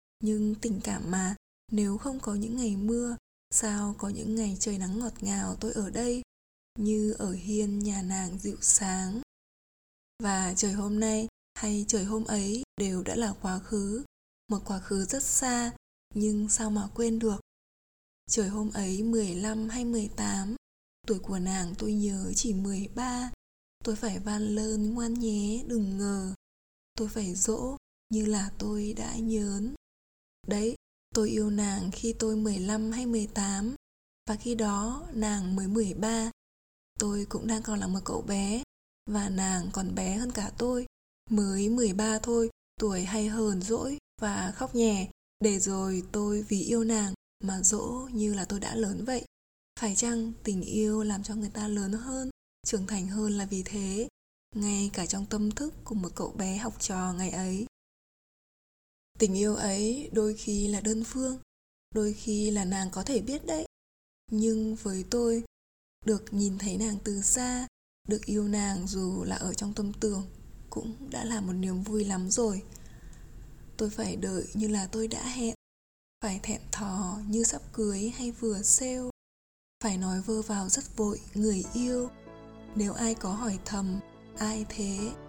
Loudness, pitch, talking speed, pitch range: -30 LUFS, 210 Hz, 165 wpm, 200-225 Hz